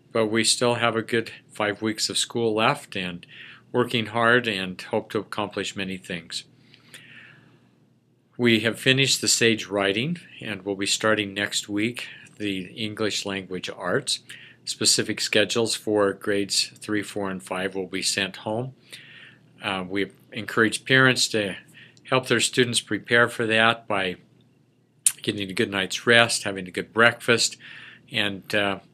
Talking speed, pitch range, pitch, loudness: 145 wpm, 100-120 Hz, 110 Hz, -23 LUFS